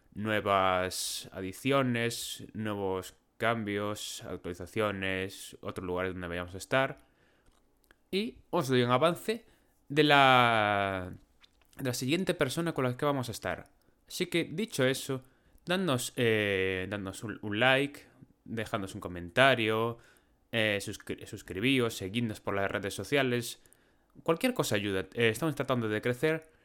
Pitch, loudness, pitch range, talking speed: 115 Hz, -30 LUFS, 95-135 Hz, 125 wpm